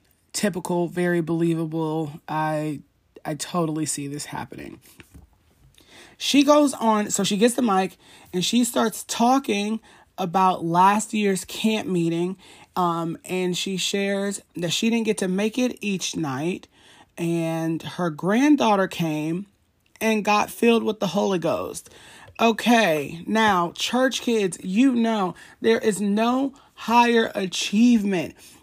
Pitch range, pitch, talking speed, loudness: 170-225 Hz, 195 Hz, 130 wpm, -22 LUFS